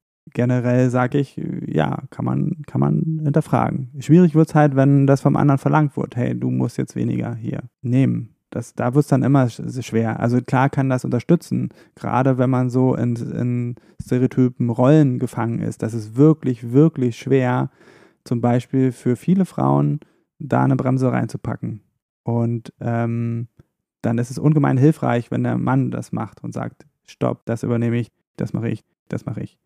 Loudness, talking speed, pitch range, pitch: -20 LUFS, 170 wpm, 115-145 Hz, 125 Hz